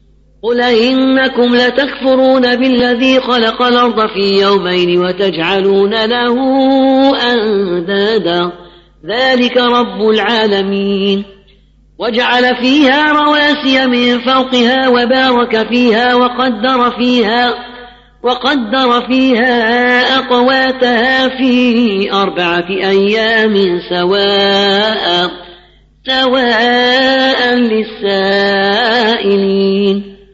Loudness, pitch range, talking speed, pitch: -11 LUFS, 200-255 Hz, 65 wpm, 240 Hz